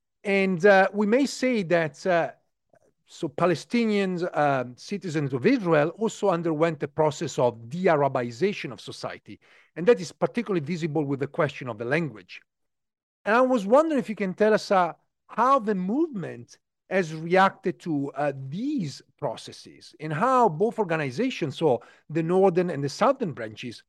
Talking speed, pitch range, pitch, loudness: 160 wpm, 150-210 Hz, 175 Hz, -25 LUFS